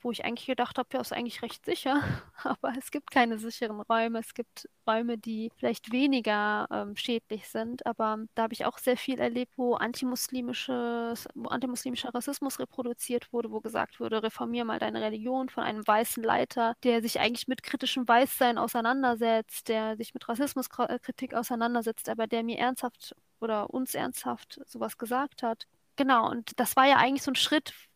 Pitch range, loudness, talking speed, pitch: 230-260 Hz, -30 LUFS, 180 wpm, 240 Hz